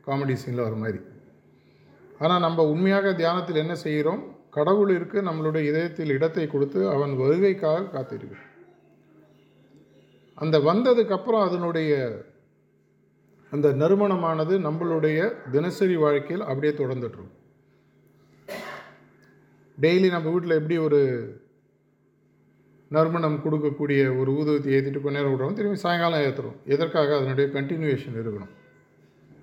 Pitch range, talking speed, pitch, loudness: 140-170 Hz, 100 wpm, 155 Hz, -24 LUFS